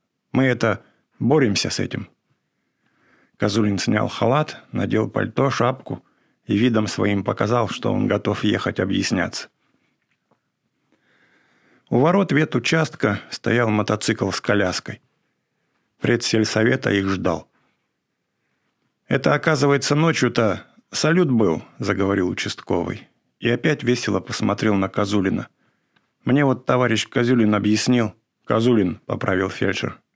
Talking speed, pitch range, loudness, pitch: 105 wpm, 105-125 Hz, -21 LUFS, 115 Hz